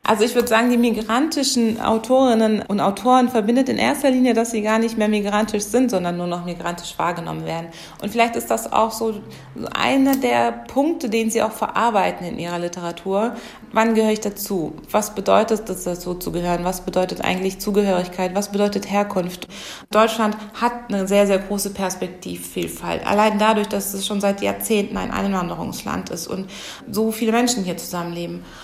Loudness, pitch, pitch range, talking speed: -20 LUFS, 210 Hz, 185-225 Hz, 170 wpm